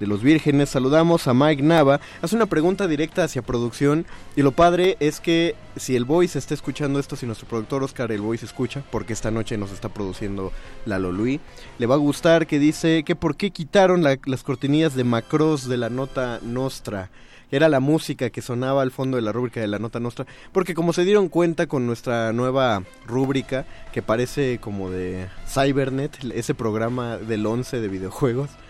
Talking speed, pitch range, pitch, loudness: 190 wpm, 115-150 Hz, 135 Hz, -22 LUFS